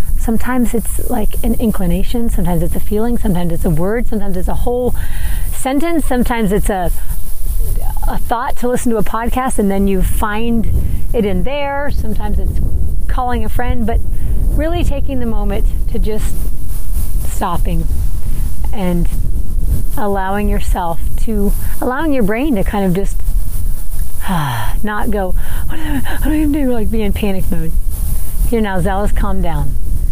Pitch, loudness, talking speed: 205 Hz, -18 LUFS, 155 wpm